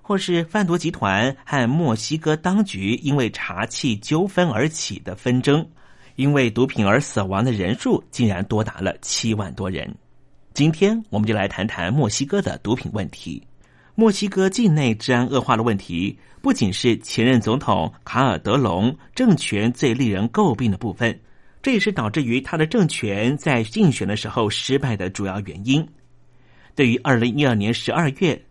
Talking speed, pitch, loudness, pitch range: 260 characters per minute, 125 Hz, -21 LUFS, 110-155 Hz